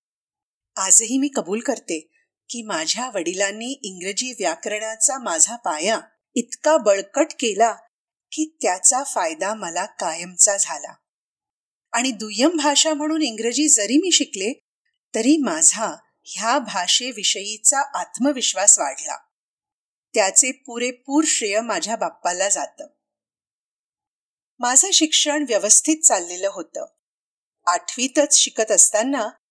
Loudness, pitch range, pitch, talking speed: -18 LUFS, 210-300 Hz, 245 Hz, 100 wpm